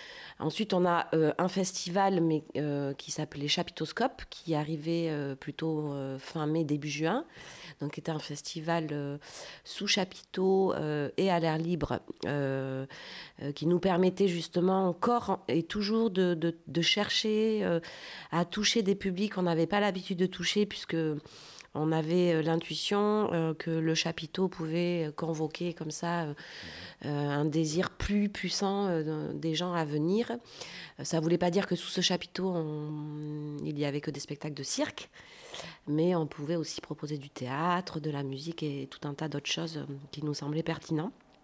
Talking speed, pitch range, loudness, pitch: 165 wpm, 150-185 Hz, -31 LUFS, 165 Hz